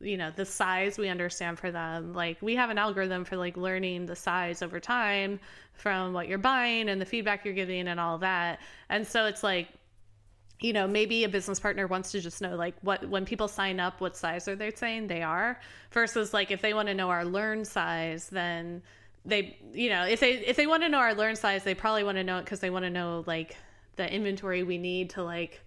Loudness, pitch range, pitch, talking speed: -30 LUFS, 175-210 Hz, 190 Hz, 235 wpm